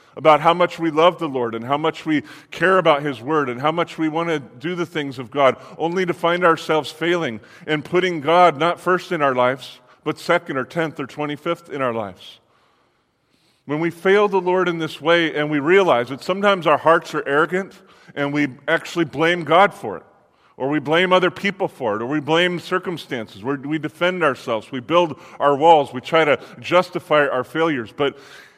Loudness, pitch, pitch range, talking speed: -19 LUFS, 160 Hz, 140-175 Hz, 205 wpm